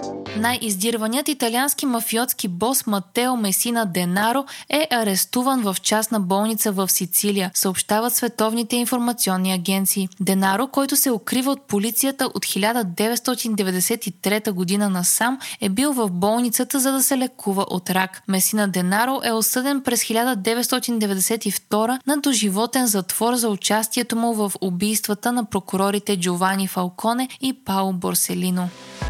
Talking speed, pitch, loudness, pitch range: 120 wpm, 220 Hz, -20 LUFS, 195-245 Hz